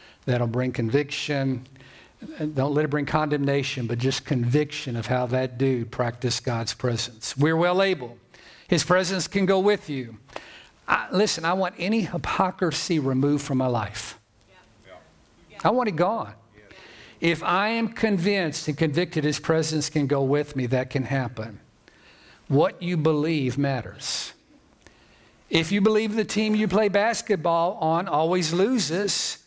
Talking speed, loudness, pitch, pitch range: 145 wpm, -24 LUFS, 150 Hz, 130-180 Hz